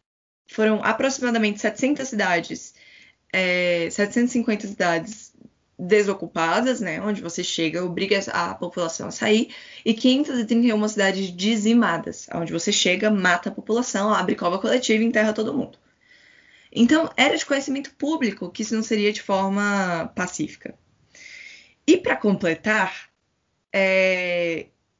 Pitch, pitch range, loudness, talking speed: 210 Hz, 180-230 Hz, -22 LUFS, 120 wpm